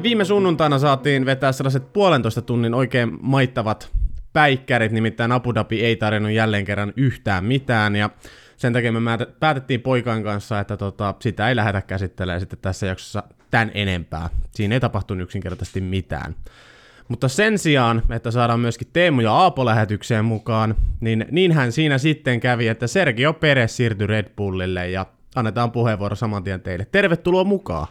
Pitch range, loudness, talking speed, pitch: 105-130 Hz, -20 LUFS, 155 wpm, 115 Hz